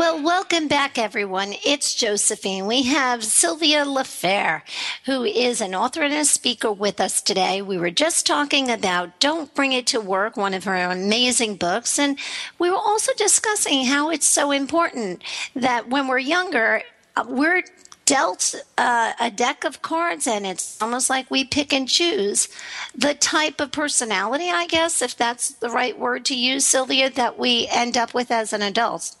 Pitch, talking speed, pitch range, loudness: 260 Hz, 175 wpm, 225-300 Hz, -20 LUFS